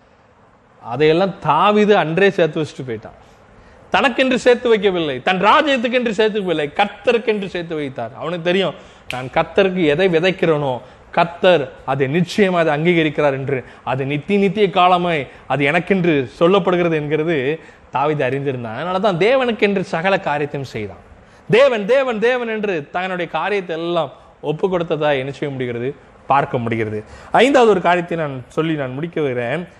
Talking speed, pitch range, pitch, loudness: 135 wpm, 140-195 Hz, 165 Hz, -17 LUFS